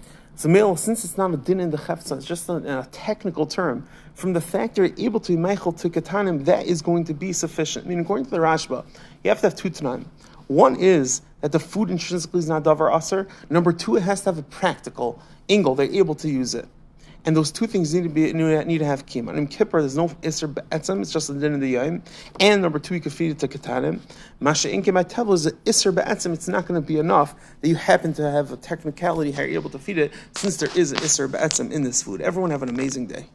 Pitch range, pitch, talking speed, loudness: 150-185 Hz, 165 Hz, 250 wpm, -22 LUFS